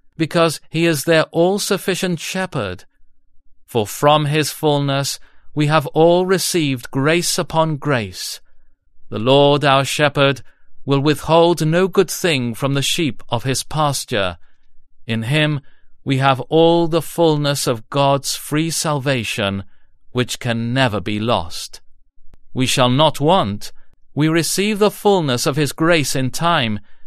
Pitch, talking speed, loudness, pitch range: 140 Hz, 135 wpm, -17 LUFS, 115-160 Hz